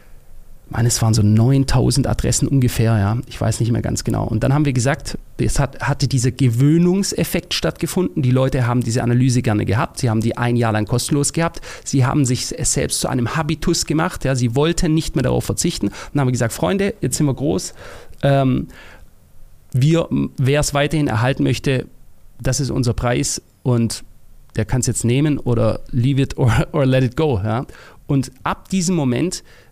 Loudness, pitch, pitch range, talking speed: -18 LUFS, 130 Hz, 120-145 Hz, 190 wpm